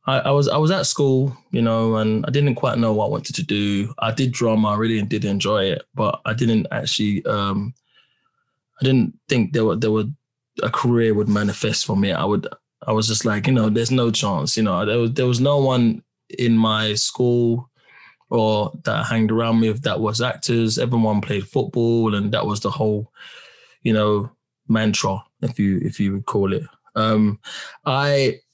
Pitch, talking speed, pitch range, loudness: 115 Hz, 200 wpm, 105-130 Hz, -20 LUFS